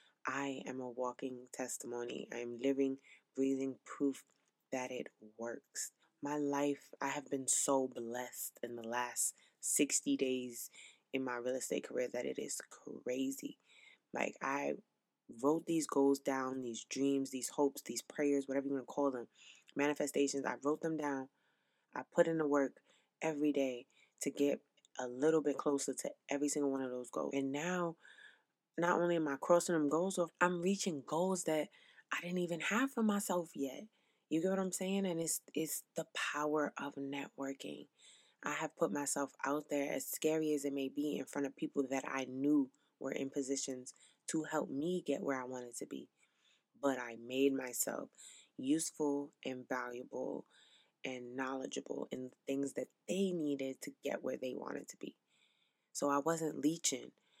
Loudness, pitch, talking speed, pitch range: -38 LUFS, 140 Hz, 175 wpm, 130-155 Hz